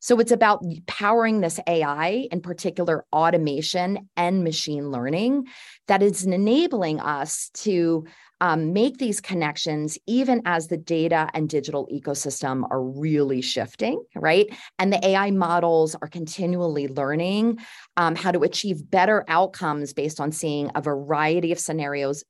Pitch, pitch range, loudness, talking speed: 170 Hz, 150-195 Hz, -23 LUFS, 140 wpm